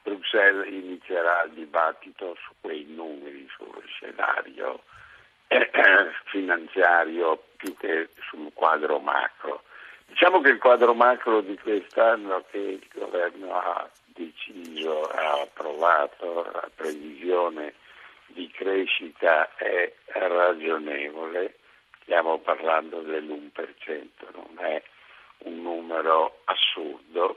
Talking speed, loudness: 95 wpm, -24 LUFS